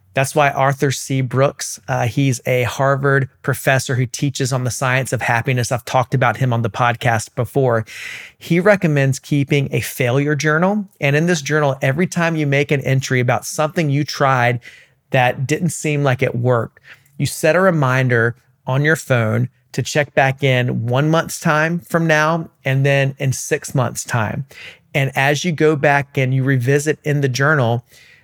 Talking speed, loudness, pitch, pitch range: 180 wpm, -17 LUFS, 135 Hz, 125-150 Hz